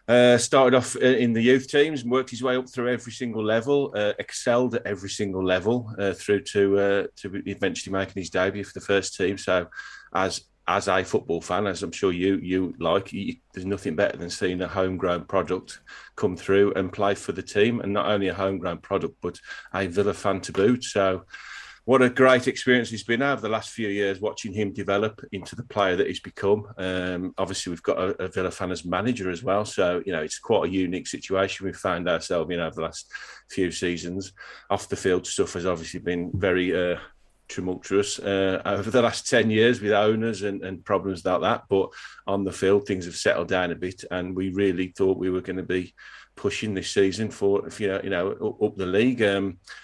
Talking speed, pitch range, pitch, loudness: 220 wpm, 95-110 Hz, 100 Hz, -25 LUFS